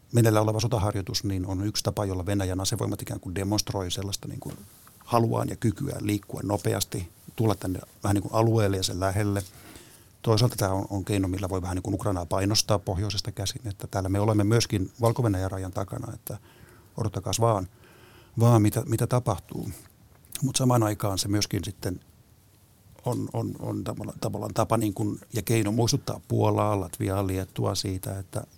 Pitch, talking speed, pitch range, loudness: 105 Hz, 165 wpm, 100-115 Hz, -27 LUFS